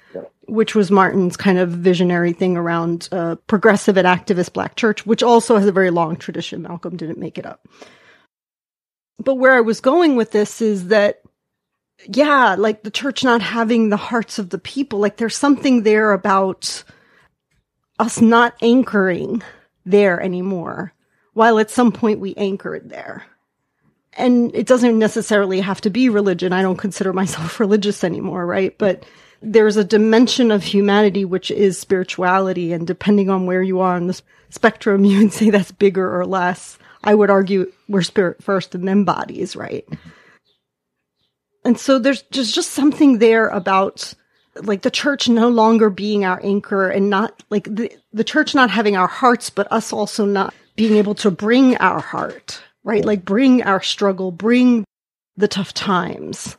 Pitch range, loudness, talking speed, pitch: 185-225 Hz, -16 LUFS, 170 wpm, 205 Hz